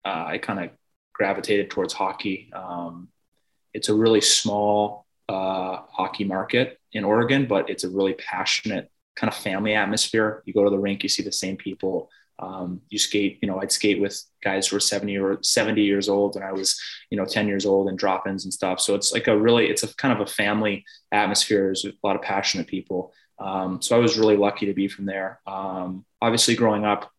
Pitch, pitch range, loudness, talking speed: 100 Hz, 95-105 Hz, -23 LUFS, 210 wpm